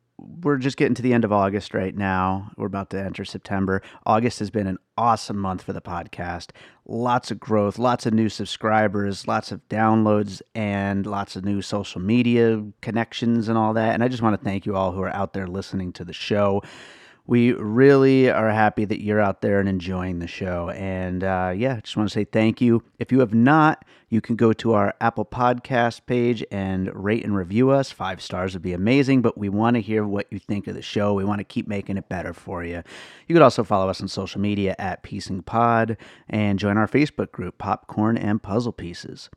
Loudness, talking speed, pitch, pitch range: -22 LUFS, 215 wpm, 105 Hz, 95-115 Hz